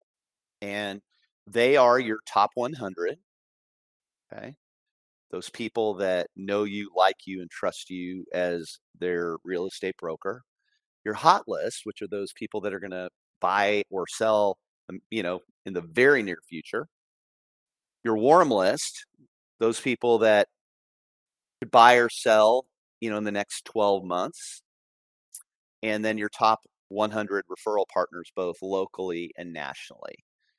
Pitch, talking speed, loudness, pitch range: 100 Hz, 140 wpm, -26 LUFS, 90-110 Hz